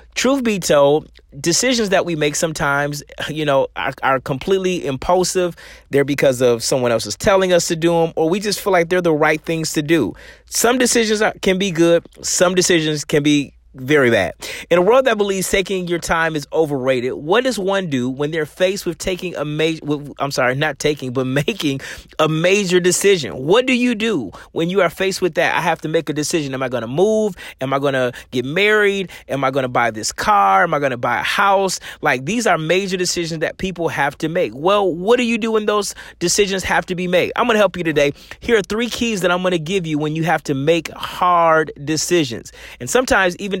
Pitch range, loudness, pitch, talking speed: 145-195 Hz, -17 LUFS, 170 Hz, 230 wpm